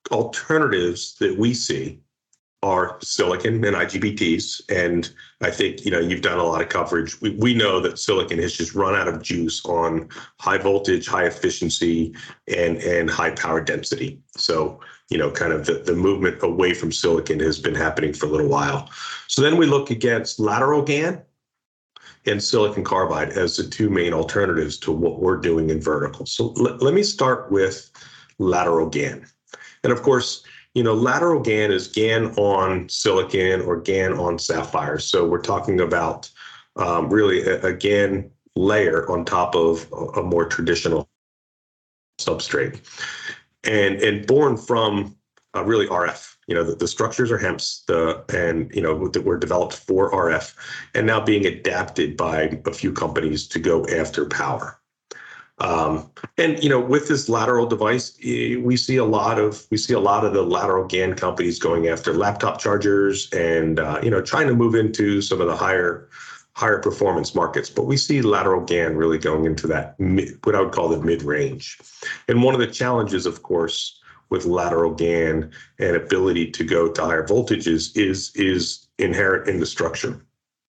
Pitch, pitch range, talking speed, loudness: 95 Hz, 85-120 Hz, 175 wpm, -21 LUFS